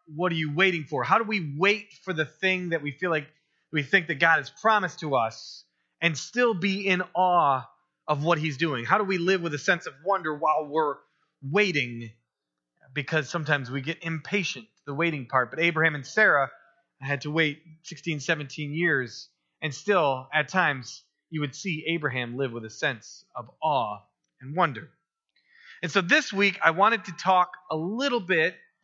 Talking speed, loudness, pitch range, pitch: 185 wpm, -26 LUFS, 145-185 Hz, 160 Hz